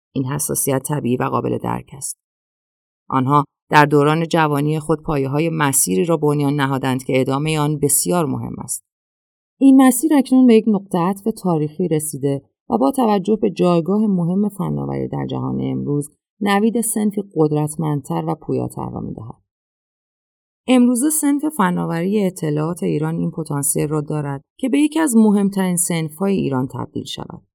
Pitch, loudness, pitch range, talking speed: 155 Hz, -18 LUFS, 135-200 Hz, 150 wpm